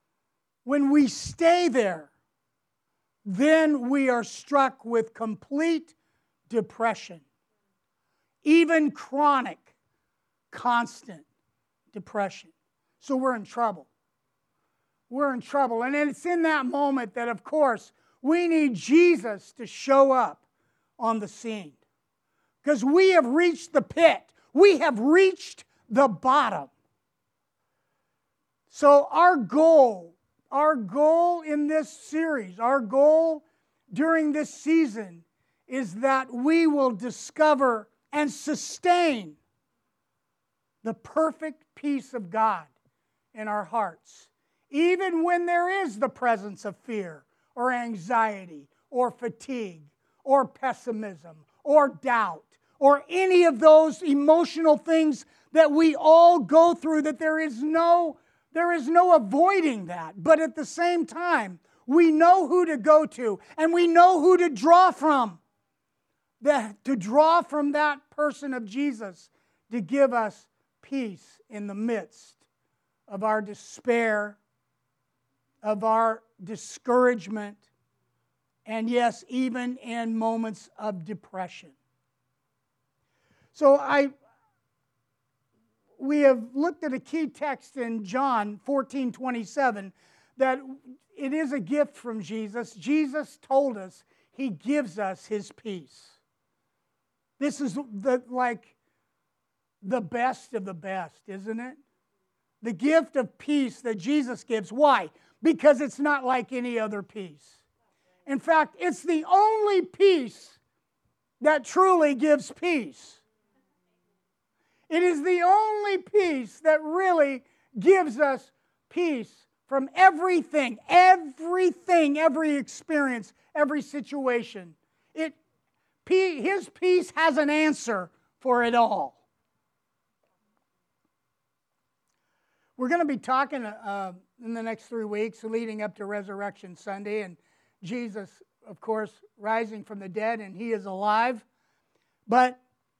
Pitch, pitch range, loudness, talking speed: 265 Hz, 220-310 Hz, -24 LUFS, 115 wpm